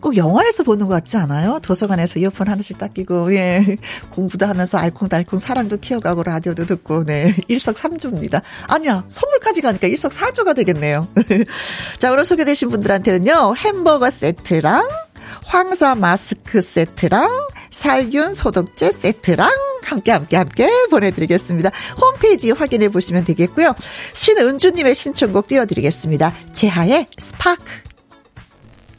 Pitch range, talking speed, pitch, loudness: 180-280 Hz, 335 characters per minute, 210 Hz, -16 LUFS